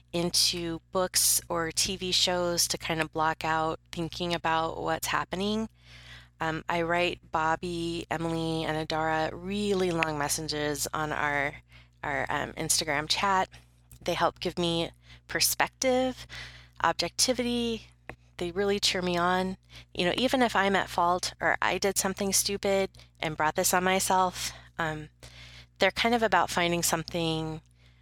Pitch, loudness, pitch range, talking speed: 165 Hz, -28 LUFS, 155-185 Hz, 140 wpm